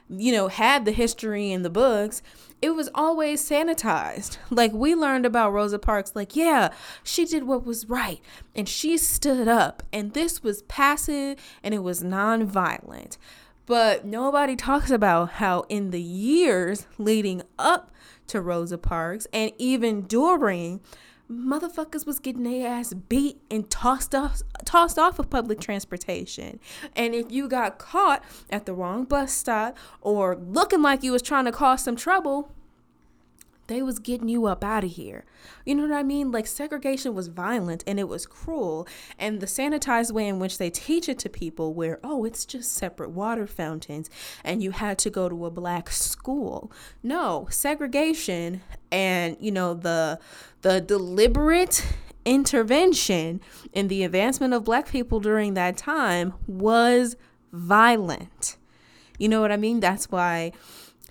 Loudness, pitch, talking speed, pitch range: -24 LUFS, 225 Hz, 160 wpm, 190-275 Hz